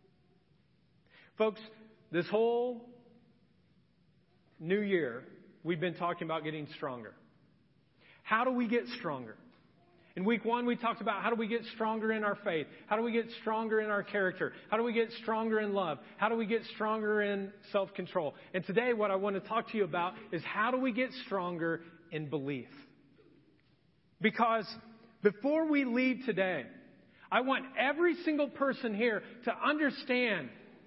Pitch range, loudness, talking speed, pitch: 185-235 Hz, -33 LUFS, 165 wpm, 220 Hz